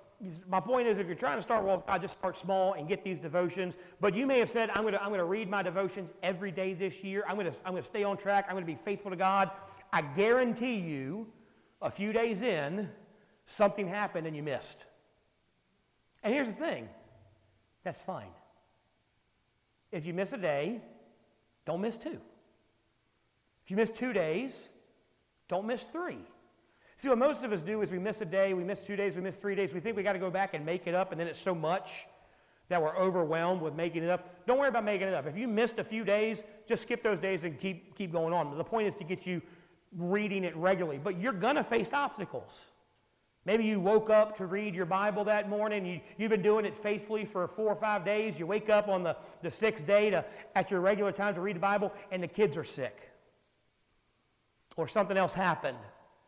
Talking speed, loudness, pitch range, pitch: 220 wpm, -32 LUFS, 180-215 Hz, 195 Hz